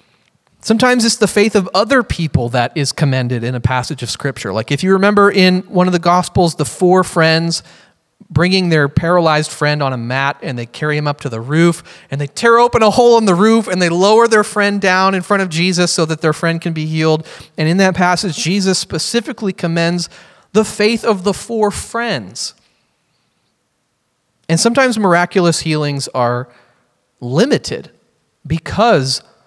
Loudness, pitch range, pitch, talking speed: -14 LUFS, 150-205 Hz, 175 Hz, 180 wpm